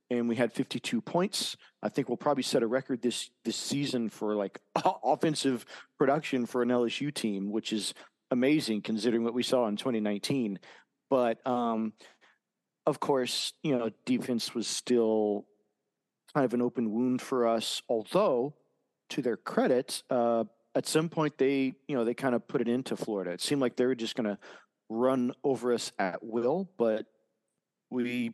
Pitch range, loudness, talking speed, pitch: 110-130 Hz, -30 LUFS, 170 wpm, 120 Hz